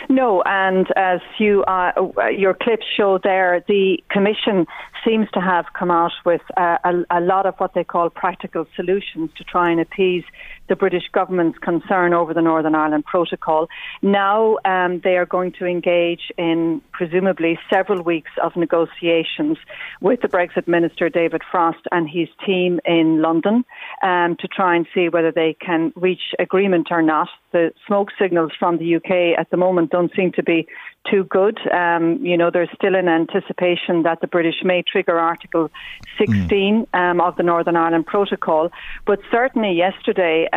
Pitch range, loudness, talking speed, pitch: 170-190 Hz, -18 LUFS, 170 wpm, 180 Hz